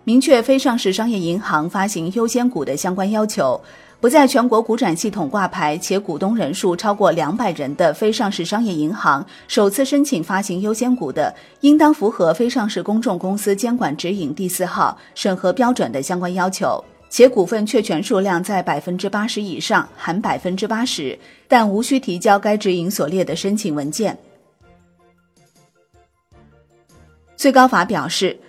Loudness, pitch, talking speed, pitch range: -18 LUFS, 200 Hz, 265 characters per minute, 180-235 Hz